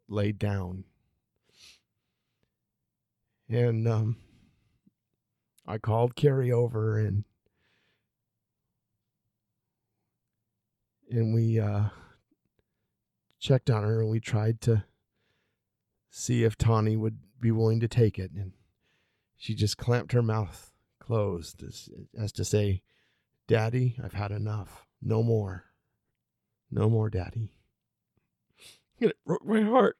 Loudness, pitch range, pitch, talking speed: -28 LUFS, 105-115 Hz, 110 Hz, 105 wpm